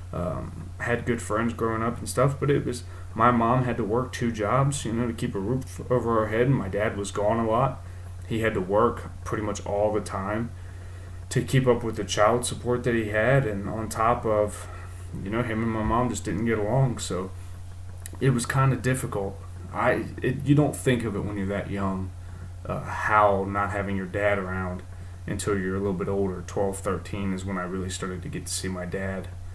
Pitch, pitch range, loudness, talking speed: 100 Hz, 90-115 Hz, -26 LUFS, 225 wpm